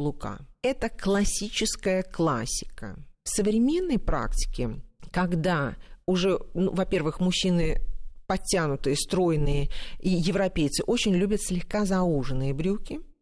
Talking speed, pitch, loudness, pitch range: 95 wpm, 185 Hz, -27 LUFS, 150-200 Hz